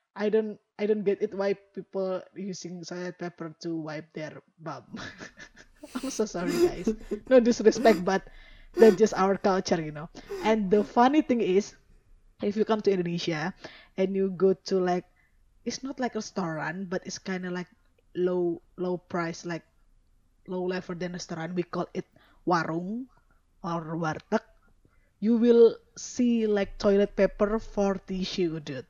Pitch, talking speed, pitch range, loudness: 190 Hz, 160 wpm, 170-215 Hz, -27 LUFS